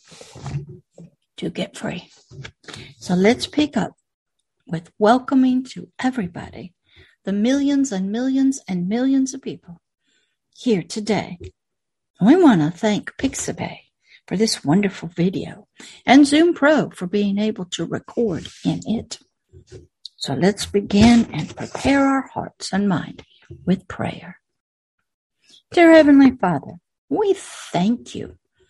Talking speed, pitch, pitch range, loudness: 120 wpm, 220 Hz, 180-270 Hz, -19 LUFS